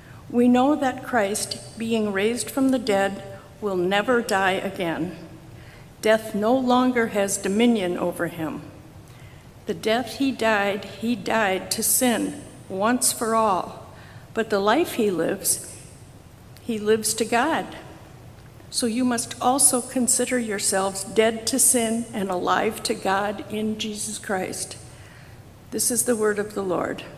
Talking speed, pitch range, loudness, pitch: 140 wpm, 195-240 Hz, -23 LUFS, 220 Hz